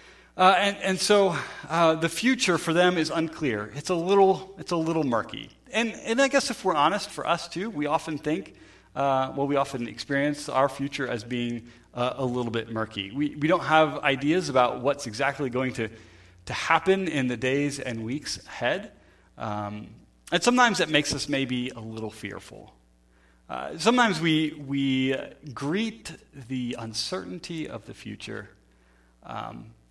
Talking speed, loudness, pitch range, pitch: 175 wpm, -26 LUFS, 120-170 Hz, 140 Hz